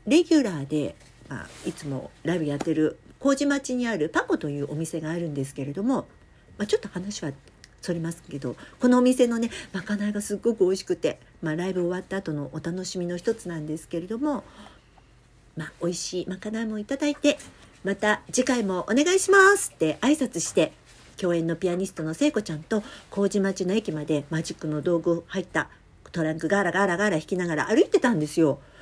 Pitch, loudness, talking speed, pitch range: 180 Hz, -26 LUFS, 390 characters per minute, 160-225 Hz